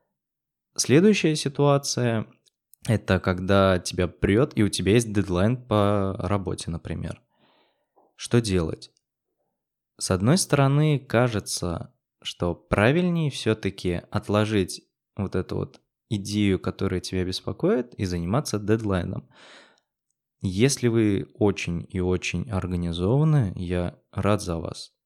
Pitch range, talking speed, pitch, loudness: 90-120 Hz, 110 wpm, 100 Hz, -24 LUFS